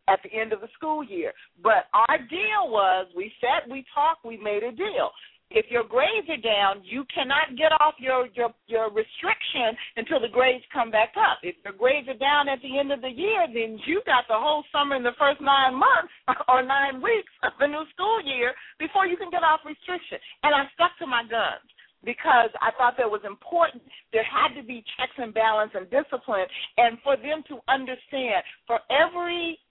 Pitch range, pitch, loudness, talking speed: 235-315 Hz, 275 Hz, -24 LUFS, 205 wpm